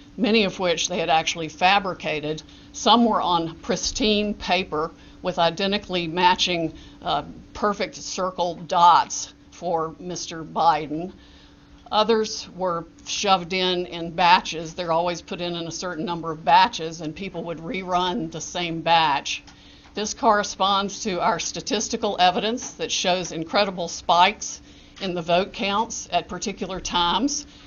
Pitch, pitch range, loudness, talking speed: 180 Hz, 165-200 Hz, -23 LUFS, 135 wpm